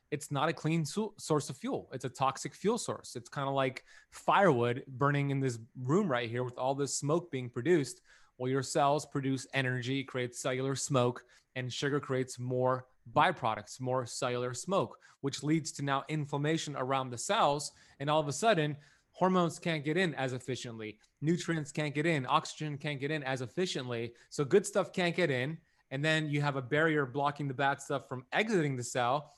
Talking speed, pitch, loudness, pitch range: 195 wpm, 140 Hz, -33 LUFS, 130-155 Hz